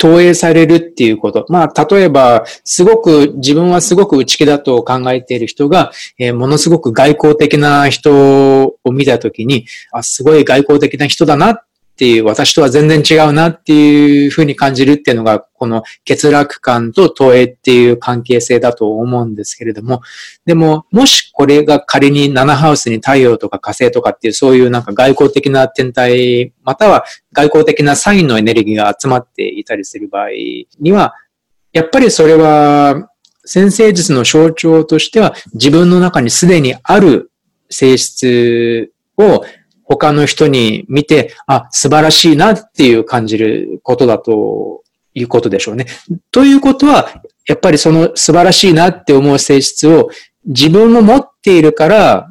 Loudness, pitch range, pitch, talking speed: -9 LUFS, 125-170 Hz, 145 Hz, 325 characters per minute